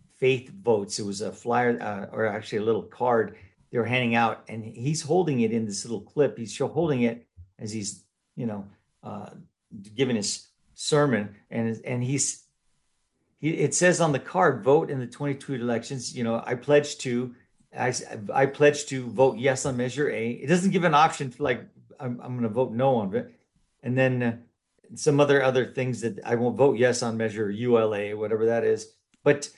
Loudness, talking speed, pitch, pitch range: -25 LUFS, 195 wpm, 125 Hz, 115-140 Hz